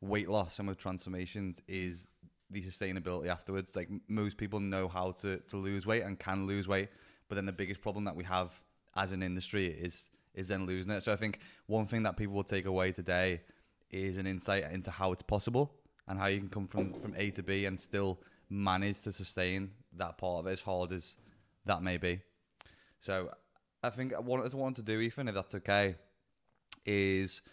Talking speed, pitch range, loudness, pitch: 205 wpm, 95-100 Hz, -37 LUFS, 95 Hz